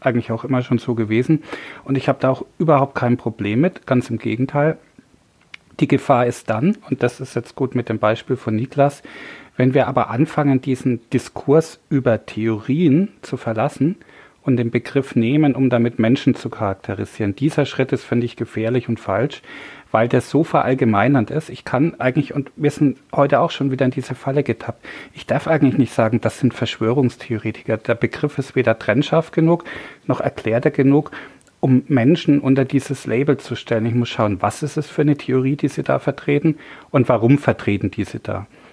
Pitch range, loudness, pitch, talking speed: 115-145 Hz, -19 LUFS, 130 Hz, 185 wpm